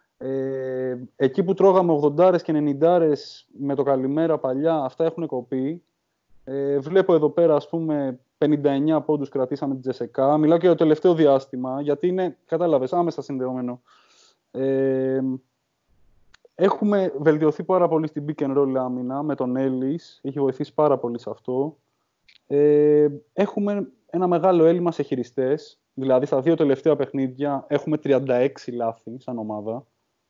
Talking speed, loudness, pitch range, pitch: 140 wpm, -22 LUFS, 130-165 Hz, 145 Hz